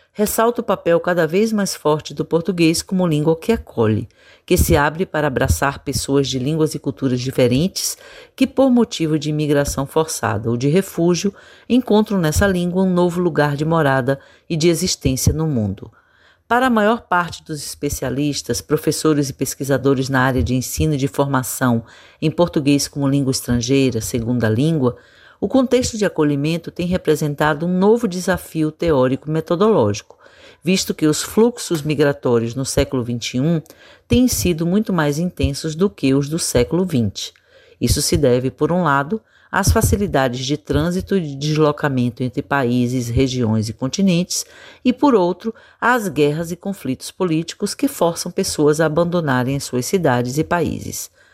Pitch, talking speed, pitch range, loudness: 155 Hz, 160 wpm, 135-180 Hz, -18 LUFS